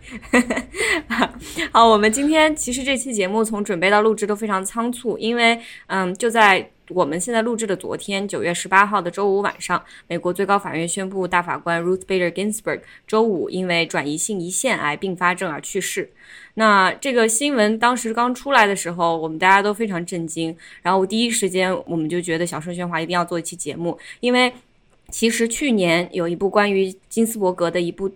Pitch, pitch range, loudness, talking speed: 195 Hz, 175-225 Hz, -20 LUFS, 330 characters per minute